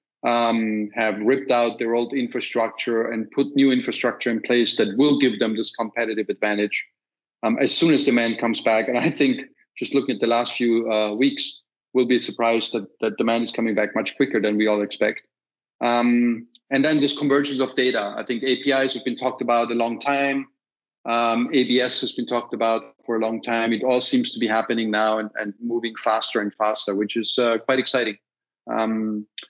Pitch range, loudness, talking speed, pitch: 110-130 Hz, -22 LUFS, 200 wpm, 115 Hz